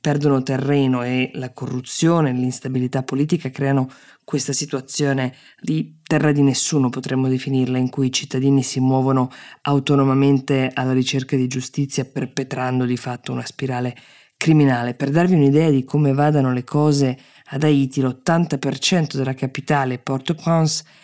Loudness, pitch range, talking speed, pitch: -20 LUFS, 130-145 Hz, 135 wpm, 135 Hz